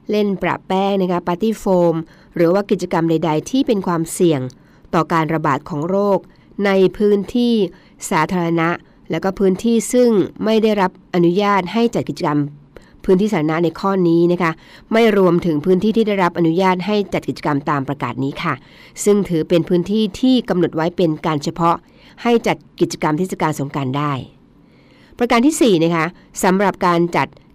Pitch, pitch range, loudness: 175 Hz, 160-200 Hz, -17 LUFS